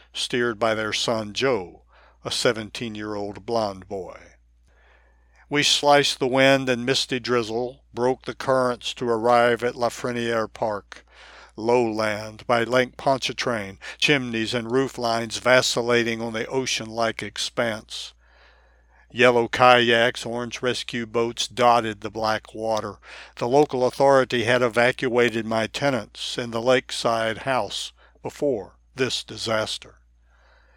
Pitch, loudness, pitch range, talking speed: 120 Hz, -22 LUFS, 110-125 Hz, 125 wpm